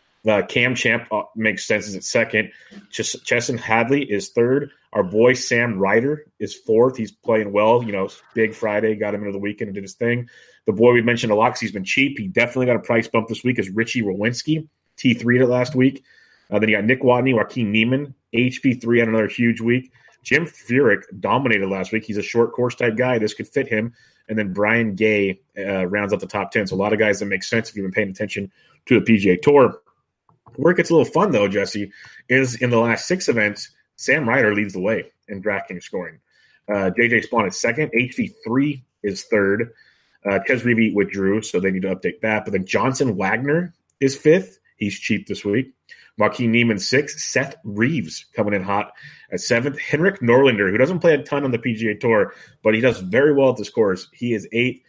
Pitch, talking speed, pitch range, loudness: 115 Hz, 215 wpm, 105-125 Hz, -20 LUFS